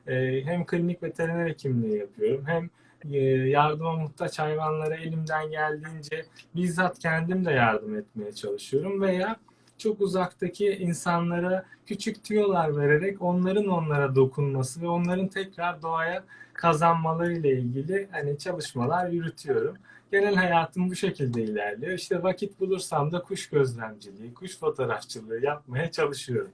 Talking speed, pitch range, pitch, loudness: 120 wpm, 145-185 Hz, 170 Hz, -27 LUFS